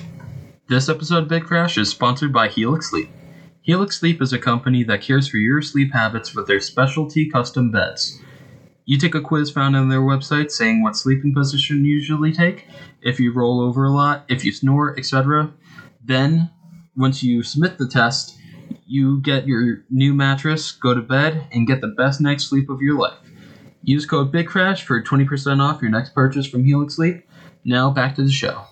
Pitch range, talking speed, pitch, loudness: 130-155 Hz, 190 wpm, 140 Hz, -18 LUFS